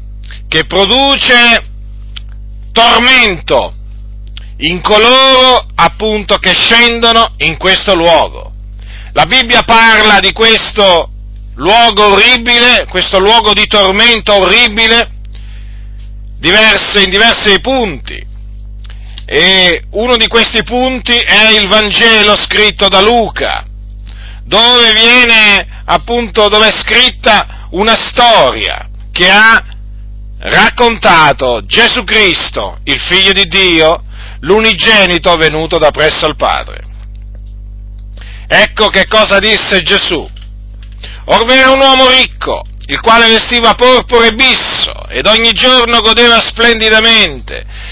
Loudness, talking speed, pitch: -5 LUFS, 100 wpm, 195 Hz